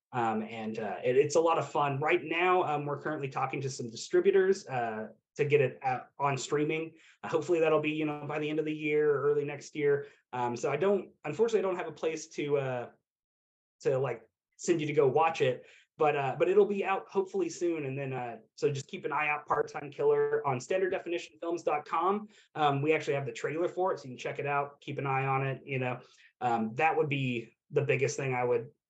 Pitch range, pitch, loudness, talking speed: 140-190 Hz, 155 Hz, -31 LUFS, 235 wpm